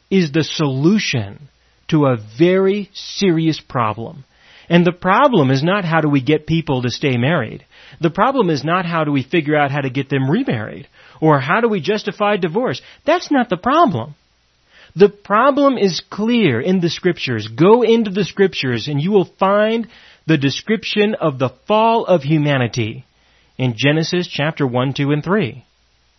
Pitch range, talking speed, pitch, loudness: 140-200 Hz, 170 wpm, 160 Hz, -16 LUFS